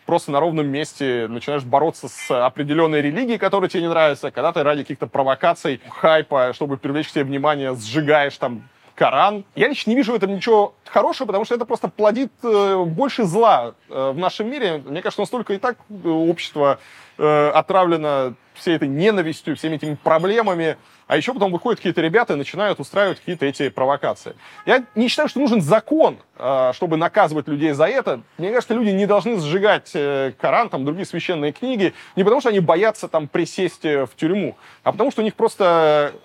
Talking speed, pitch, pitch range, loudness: 175 wpm, 170 Hz, 145-205 Hz, -19 LUFS